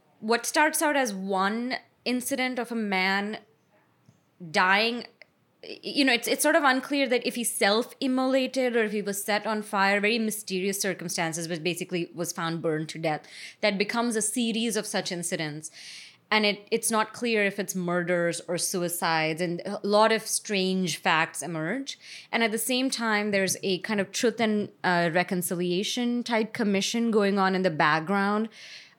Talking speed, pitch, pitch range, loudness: 170 wpm, 205 Hz, 180-230 Hz, -26 LUFS